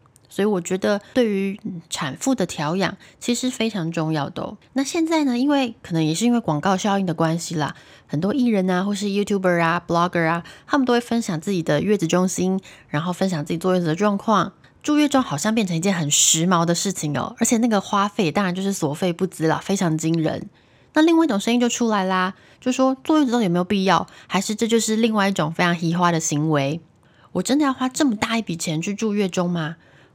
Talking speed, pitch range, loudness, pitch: 360 characters per minute, 165-225 Hz, -21 LUFS, 190 Hz